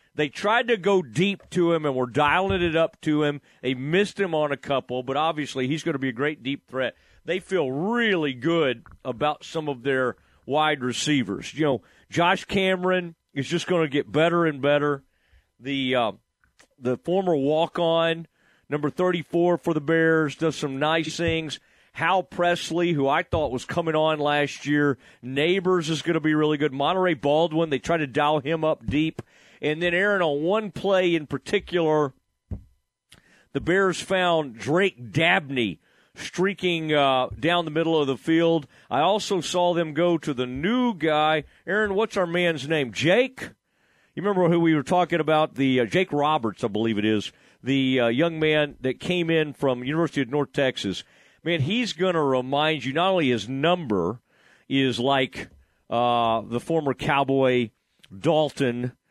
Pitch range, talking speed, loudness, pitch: 135-175 Hz, 175 wpm, -24 LUFS, 155 Hz